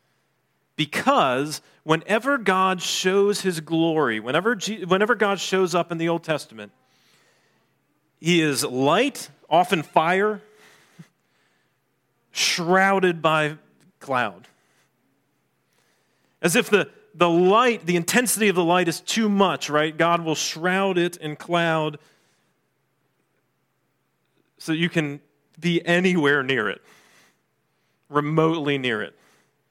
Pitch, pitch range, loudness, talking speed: 170 Hz, 155-190 Hz, -21 LUFS, 110 wpm